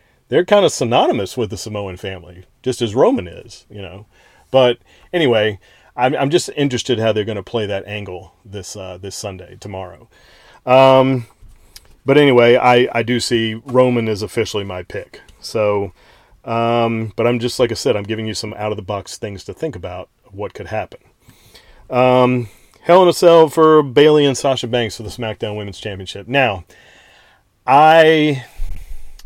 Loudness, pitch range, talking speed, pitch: -15 LUFS, 100-125 Hz, 170 wpm, 110 Hz